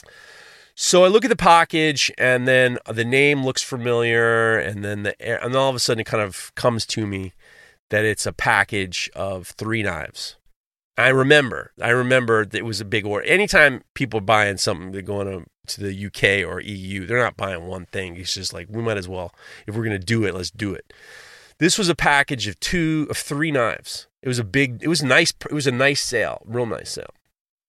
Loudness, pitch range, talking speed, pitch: -20 LUFS, 100-135 Hz, 220 wpm, 115 Hz